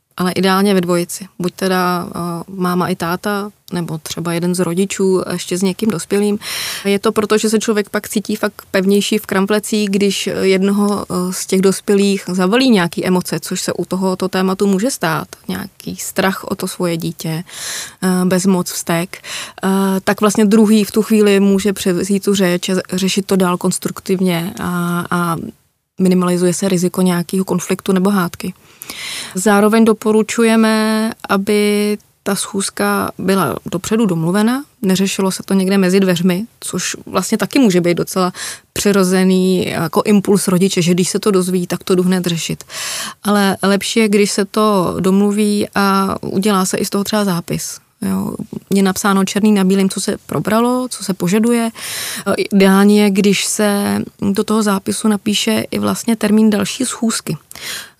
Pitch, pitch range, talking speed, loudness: 195 Hz, 185-210 Hz, 160 wpm, -15 LUFS